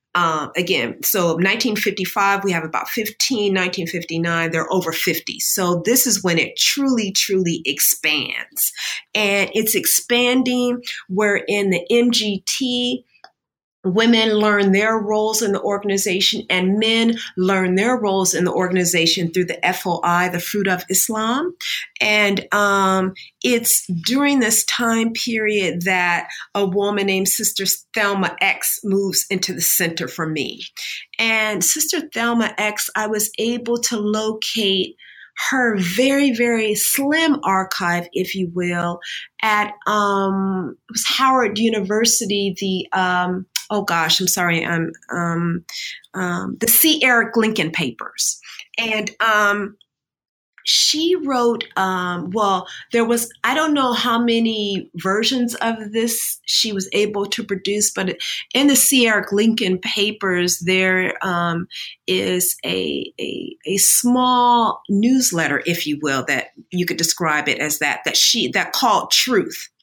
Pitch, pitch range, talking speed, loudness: 205 Hz, 185-230 Hz, 135 wpm, -18 LUFS